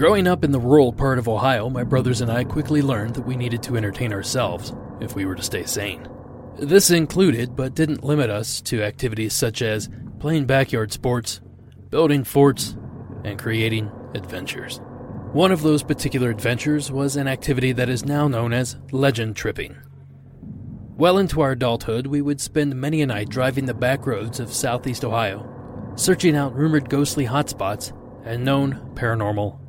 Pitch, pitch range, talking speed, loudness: 125 Hz, 115-140 Hz, 170 wpm, -21 LUFS